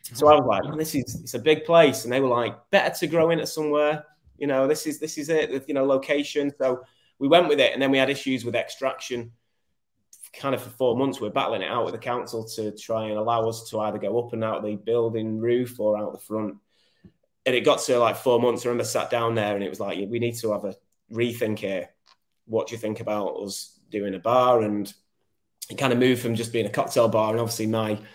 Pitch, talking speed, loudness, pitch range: 120 Hz, 255 wpm, -24 LUFS, 110-135 Hz